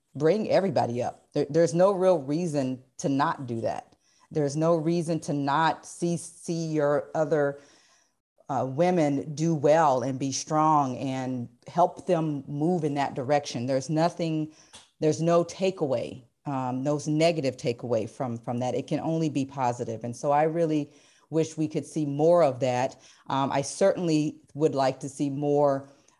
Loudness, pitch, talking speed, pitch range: -27 LUFS, 150 Hz, 165 wpm, 135-160 Hz